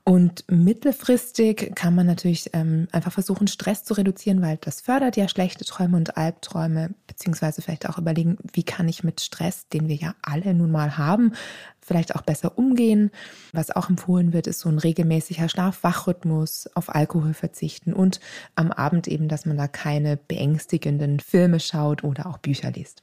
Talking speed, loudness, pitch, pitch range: 170 wpm, -23 LUFS, 170 Hz, 160-190 Hz